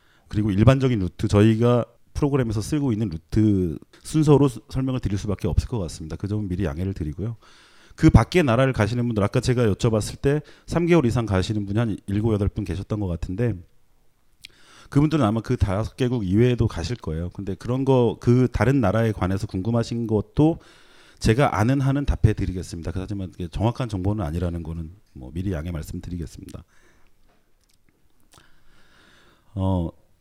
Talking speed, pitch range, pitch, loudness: 350 characters per minute, 95-120 Hz, 105 Hz, -23 LUFS